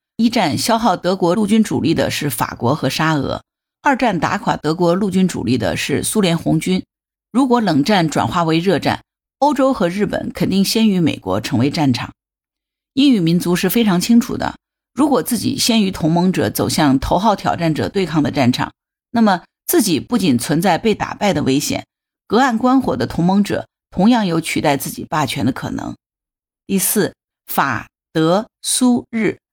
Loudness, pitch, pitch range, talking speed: -17 LUFS, 185 Hz, 155-230 Hz, 260 characters per minute